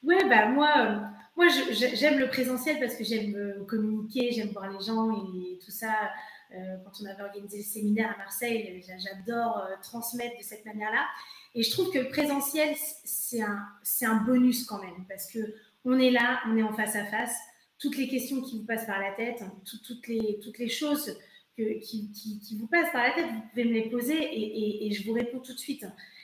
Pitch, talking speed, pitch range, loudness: 225 Hz, 230 wpm, 210-250 Hz, -29 LUFS